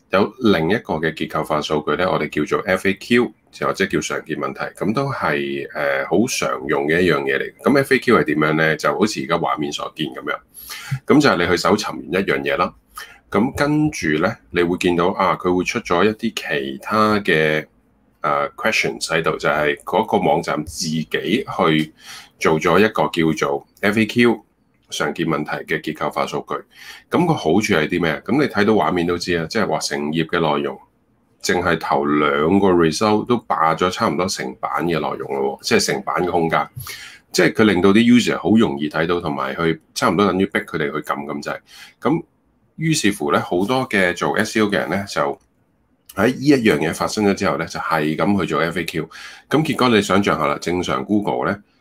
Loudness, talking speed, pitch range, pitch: -19 LUFS, 305 characters per minute, 80-105 Hz, 90 Hz